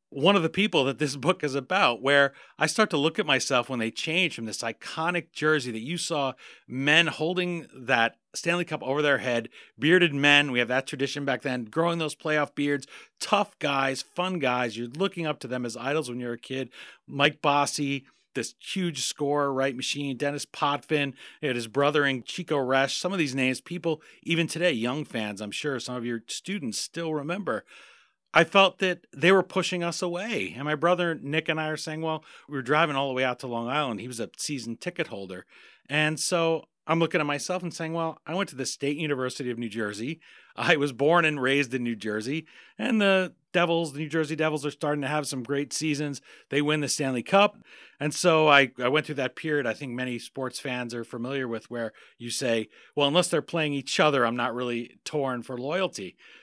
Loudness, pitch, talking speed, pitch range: -26 LUFS, 145 Hz, 215 wpm, 130-165 Hz